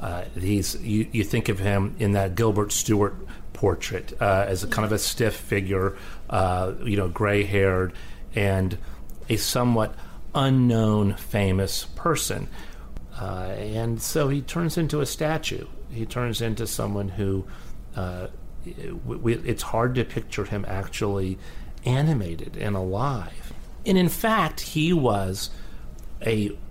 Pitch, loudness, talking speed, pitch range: 100 Hz, -25 LUFS, 135 wpm, 95-115 Hz